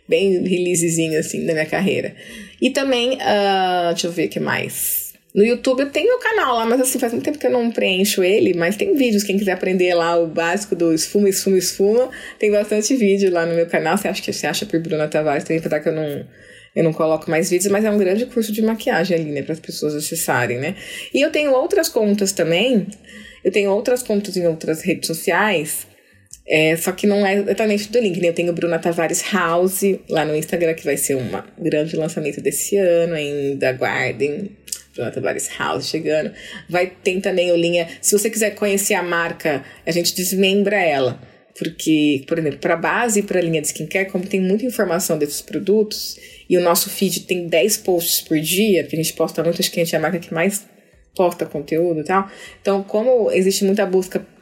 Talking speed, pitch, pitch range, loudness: 215 wpm, 180 Hz, 165-205 Hz, -19 LUFS